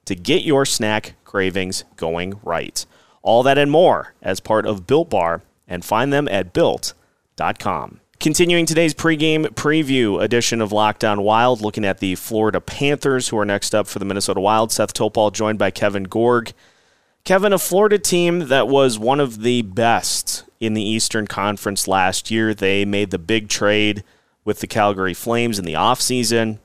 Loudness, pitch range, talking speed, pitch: -18 LUFS, 100-135 Hz, 170 wpm, 110 Hz